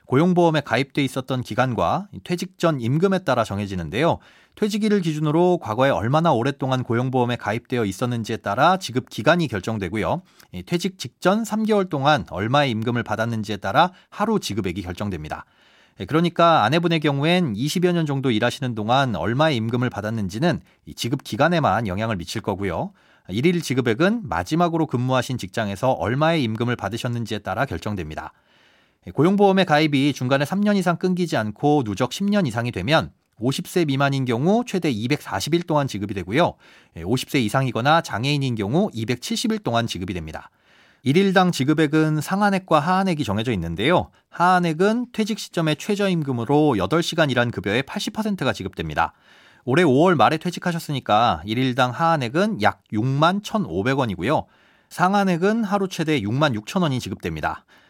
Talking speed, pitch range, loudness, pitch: 355 characters per minute, 115-175 Hz, -21 LUFS, 140 Hz